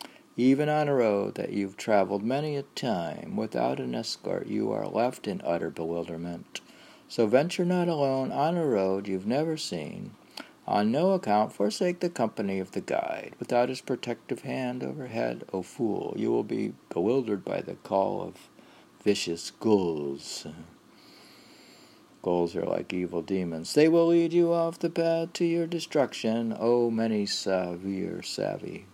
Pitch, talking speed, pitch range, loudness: 115 Hz, 160 wpm, 95-155 Hz, -28 LUFS